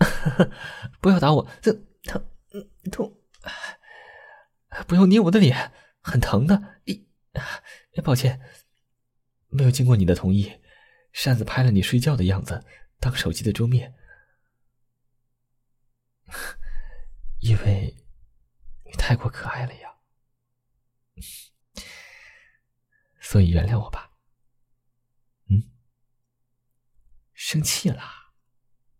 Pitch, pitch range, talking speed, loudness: 125 Hz, 120-130 Hz, 135 characters per minute, -22 LUFS